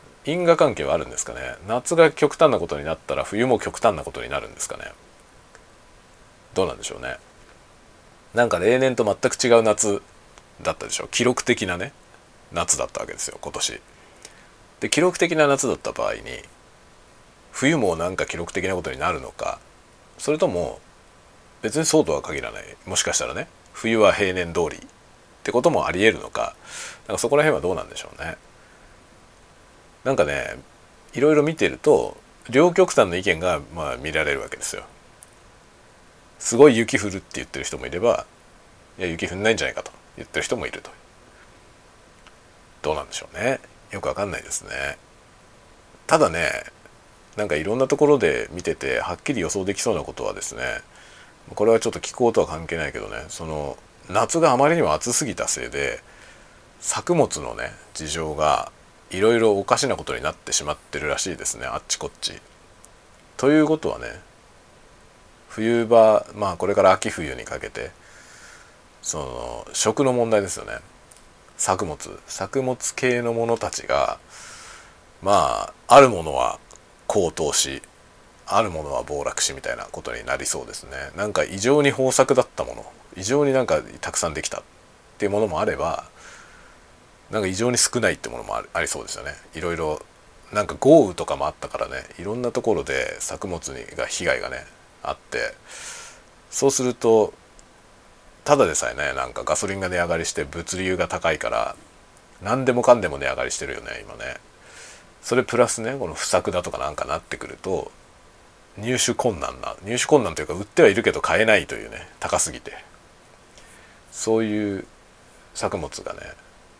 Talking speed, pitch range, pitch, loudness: 335 characters per minute, 95-135 Hz, 115 Hz, -22 LUFS